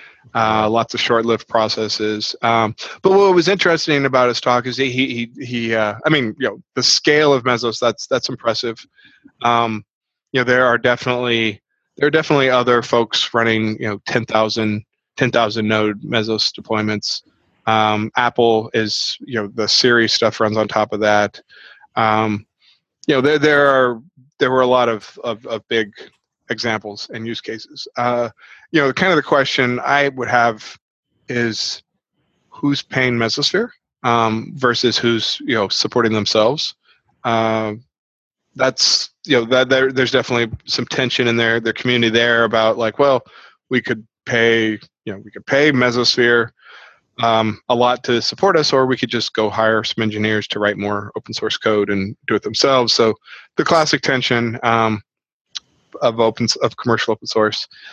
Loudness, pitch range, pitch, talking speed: -17 LUFS, 110-125 Hz, 115 Hz, 170 wpm